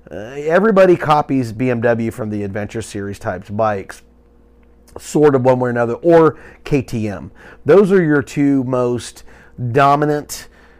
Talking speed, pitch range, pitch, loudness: 130 wpm, 105-145 Hz, 120 Hz, -16 LUFS